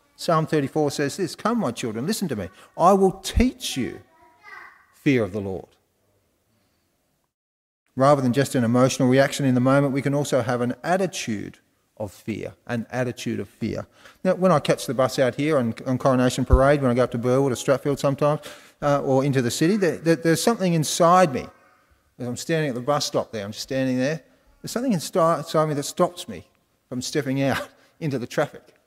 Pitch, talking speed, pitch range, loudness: 140 Hz, 195 wpm, 125-160 Hz, -22 LUFS